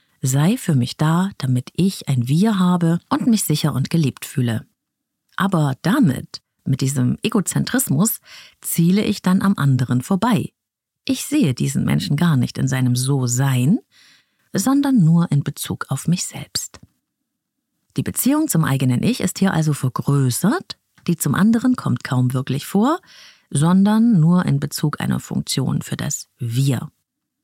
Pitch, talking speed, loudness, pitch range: 165 Hz, 150 wpm, -19 LUFS, 135-200 Hz